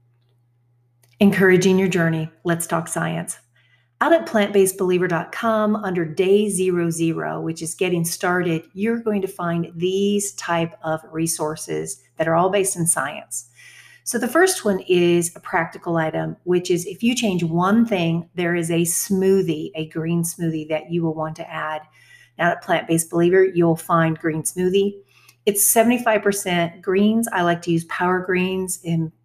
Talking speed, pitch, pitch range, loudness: 160 wpm, 175 Hz, 160-195 Hz, -20 LUFS